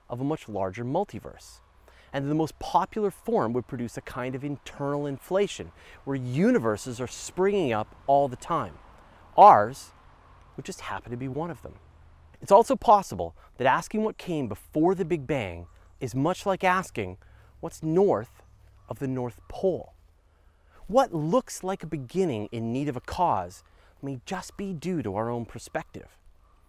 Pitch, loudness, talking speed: 130 Hz, -27 LUFS, 165 wpm